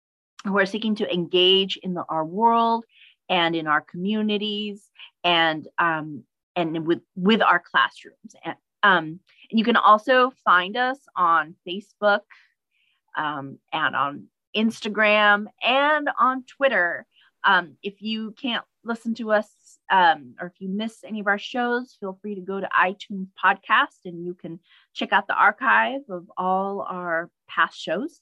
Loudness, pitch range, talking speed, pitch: -22 LUFS, 180-225 Hz, 155 wpm, 205 Hz